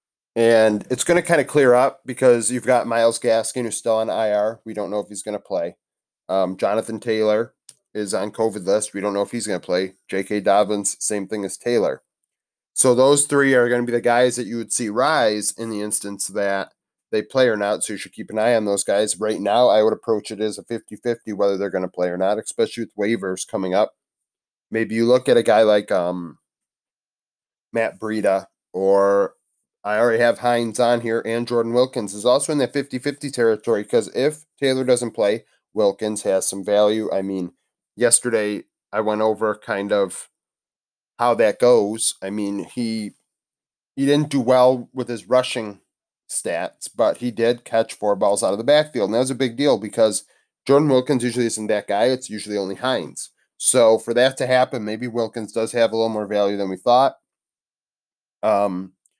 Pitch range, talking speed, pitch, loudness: 105-125 Hz, 205 wpm, 110 Hz, -20 LUFS